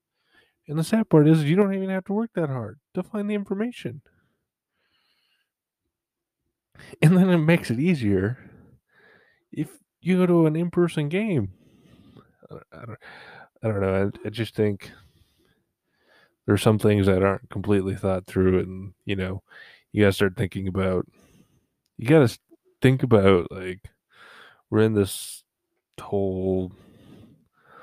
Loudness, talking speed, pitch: -23 LUFS, 150 wpm, 110 Hz